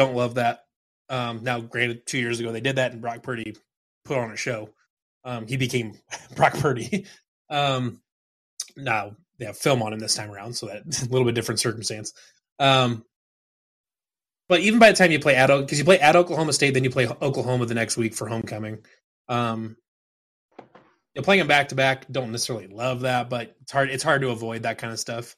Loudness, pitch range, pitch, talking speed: -23 LUFS, 115-135 Hz, 125 Hz, 210 wpm